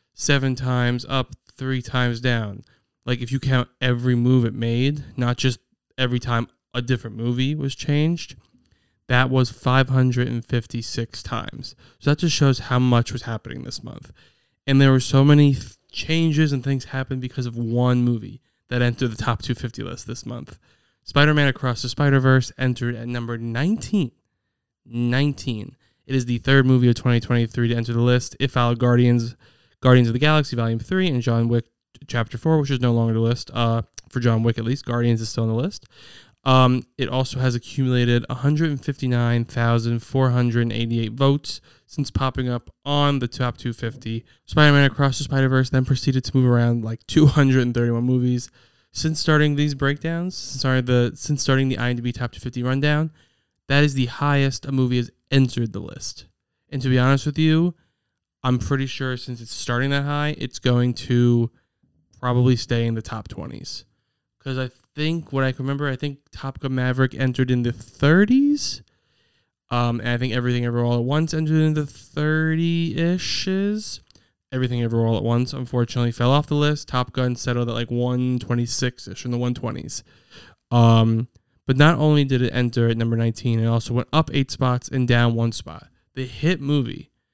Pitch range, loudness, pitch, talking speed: 120-135 Hz, -21 LUFS, 125 Hz, 190 wpm